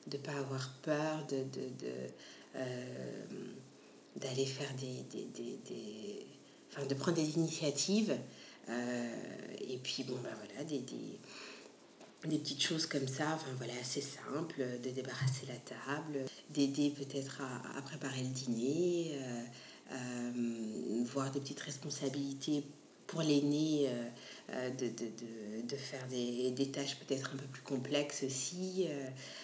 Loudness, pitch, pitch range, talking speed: -39 LUFS, 135 Hz, 125-145 Hz, 145 wpm